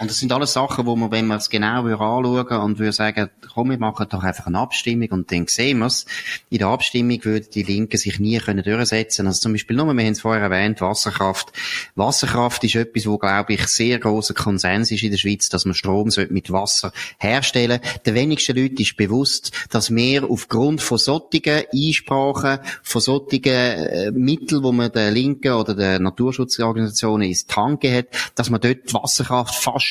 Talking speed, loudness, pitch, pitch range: 200 wpm, -19 LUFS, 115 Hz, 105-125 Hz